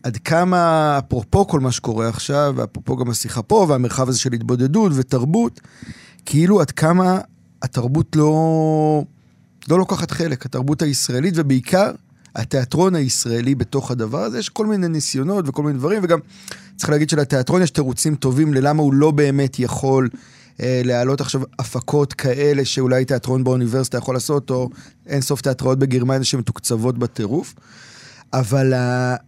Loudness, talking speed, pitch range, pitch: -18 LUFS, 140 wpm, 125-155 Hz, 135 Hz